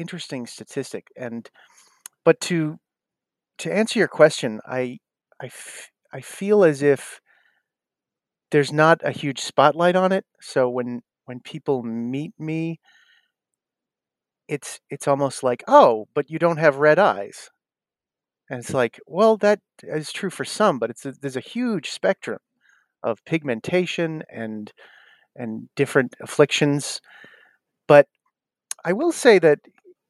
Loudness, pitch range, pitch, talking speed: -21 LUFS, 130-185 Hz, 150 Hz, 135 wpm